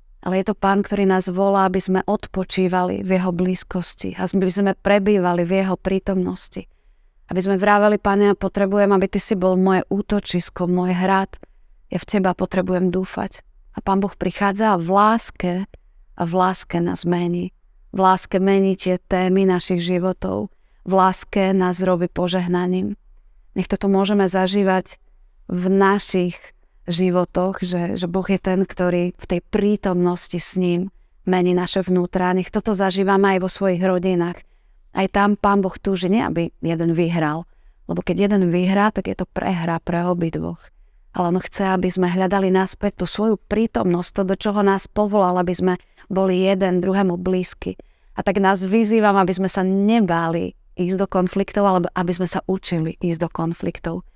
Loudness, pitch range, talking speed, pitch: -20 LUFS, 180-195 Hz, 165 wpm, 185 Hz